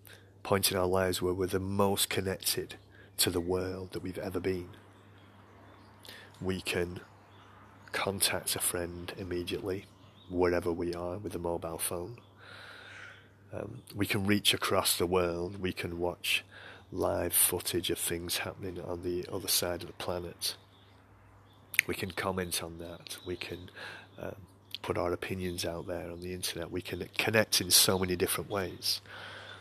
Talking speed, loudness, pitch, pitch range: 150 wpm, -32 LUFS, 95 Hz, 90-100 Hz